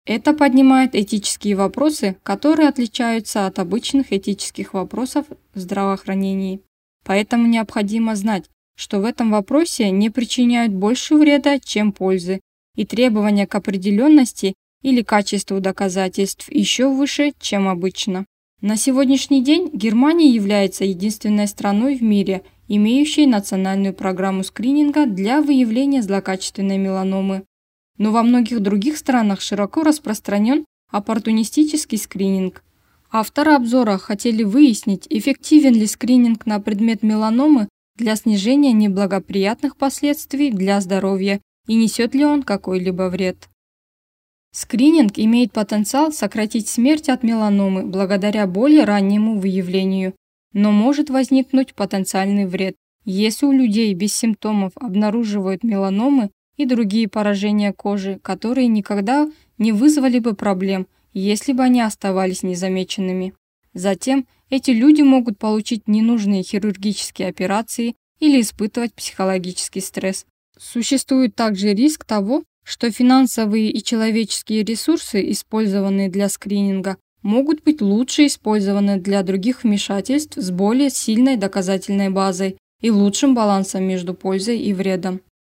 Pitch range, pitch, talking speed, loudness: 195-255 Hz, 215 Hz, 115 wpm, -18 LUFS